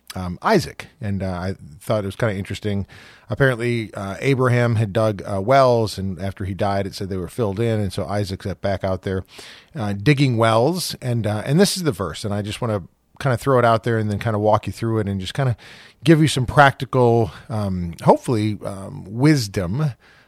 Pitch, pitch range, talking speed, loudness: 110 Hz, 100-125 Hz, 225 wpm, -20 LUFS